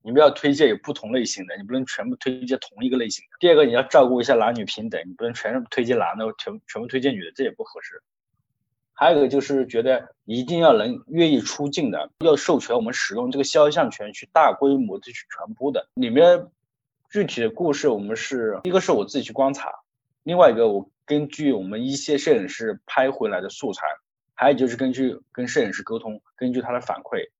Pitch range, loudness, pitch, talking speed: 125-170 Hz, -21 LUFS, 135 Hz, 335 characters per minute